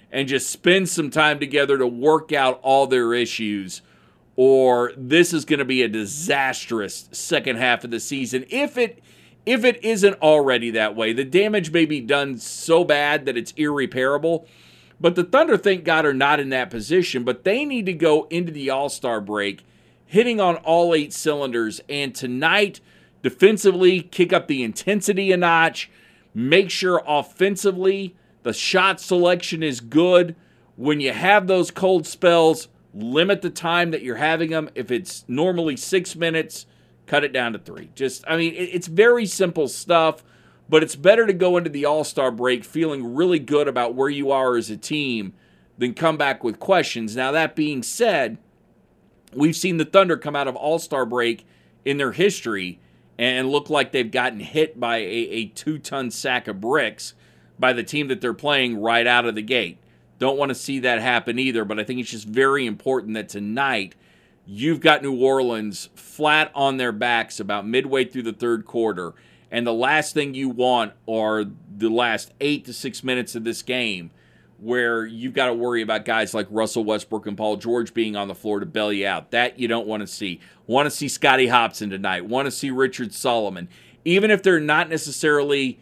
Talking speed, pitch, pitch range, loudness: 185 wpm, 135 Hz, 120-165 Hz, -21 LUFS